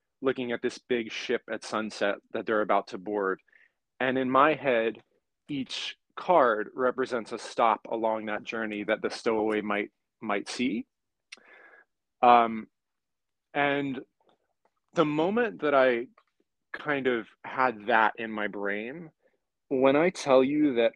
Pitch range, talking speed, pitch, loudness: 110-135 Hz, 135 wpm, 120 Hz, -28 LUFS